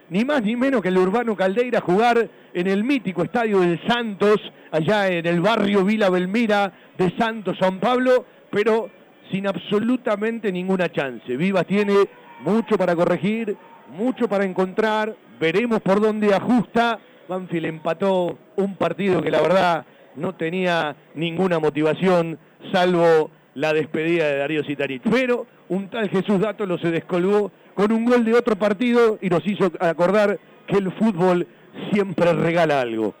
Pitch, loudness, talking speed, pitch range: 190 Hz, -21 LUFS, 150 wpm, 170-215 Hz